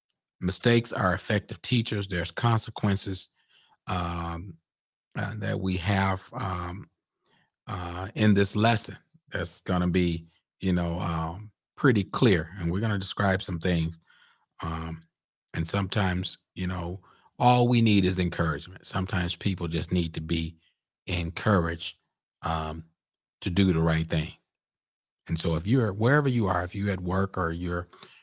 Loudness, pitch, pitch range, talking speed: -27 LUFS, 95 Hz, 85-105 Hz, 140 wpm